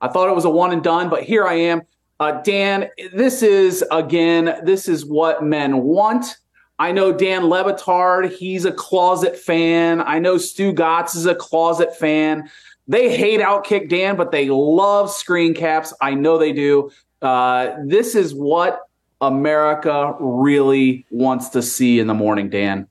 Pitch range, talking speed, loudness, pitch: 145-185 Hz, 170 wpm, -17 LUFS, 165 Hz